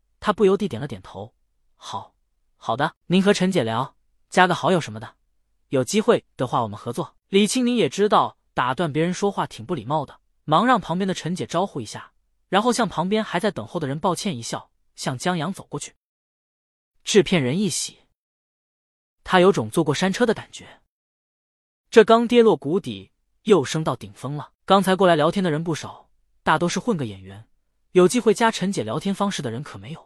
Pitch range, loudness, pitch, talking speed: 135-200 Hz, -21 LUFS, 175 Hz, 280 characters per minute